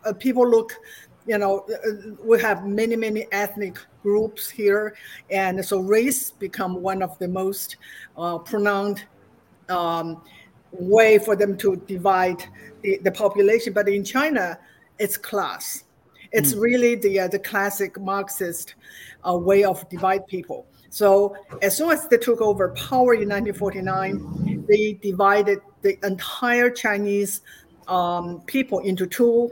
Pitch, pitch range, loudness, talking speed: 200 Hz, 190-220 Hz, -22 LUFS, 140 wpm